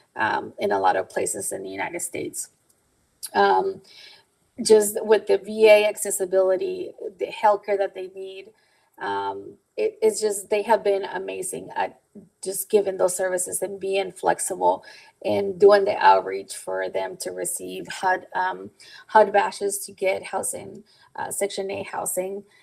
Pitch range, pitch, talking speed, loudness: 190-215 Hz, 200 Hz, 150 wpm, -23 LUFS